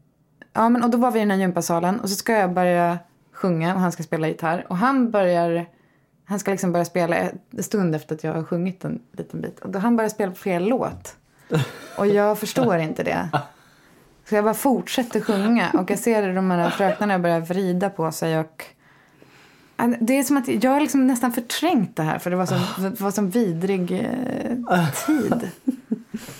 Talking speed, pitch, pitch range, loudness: 195 wpm, 195 Hz, 175-230 Hz, -22 LUFS